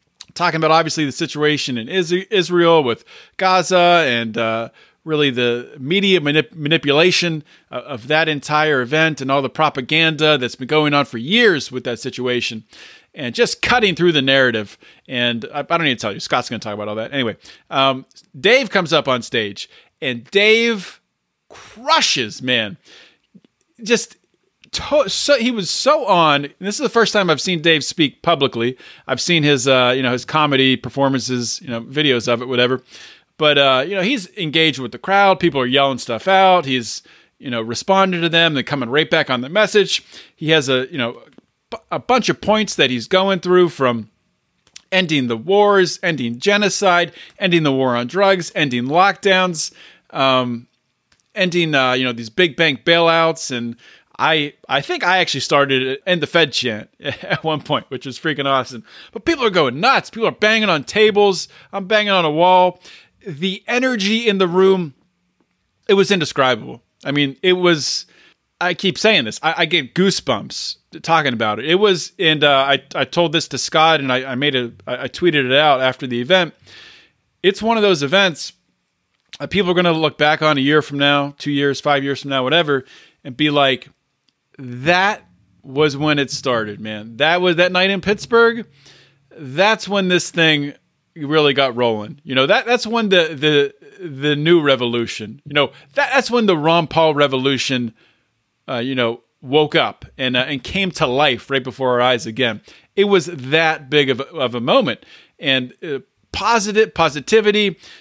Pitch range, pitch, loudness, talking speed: 130-180 Hz, 150 Hz, -16 LUFS, 185 wpm